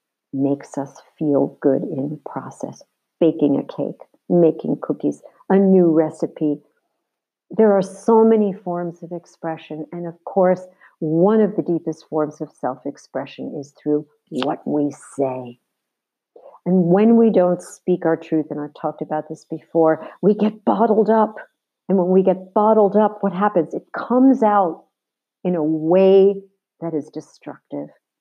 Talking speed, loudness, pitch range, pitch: 155 wpm, -19 LUFS, 155-195 Hz, 170 Hz